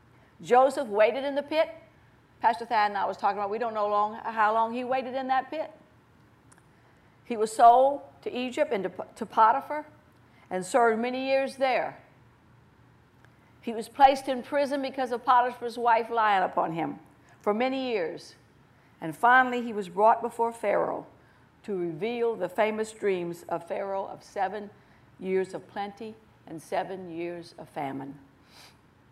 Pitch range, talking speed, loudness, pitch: 200-260 Hz, 155 wpm, -27 LUFS, 225 Hz